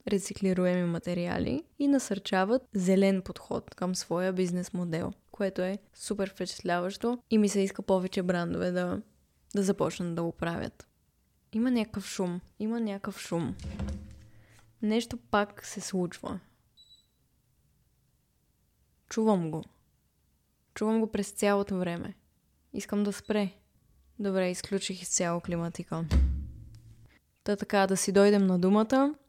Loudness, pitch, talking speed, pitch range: -30 LUFS, 190 Hz, 115 wpm, 175-205 Hz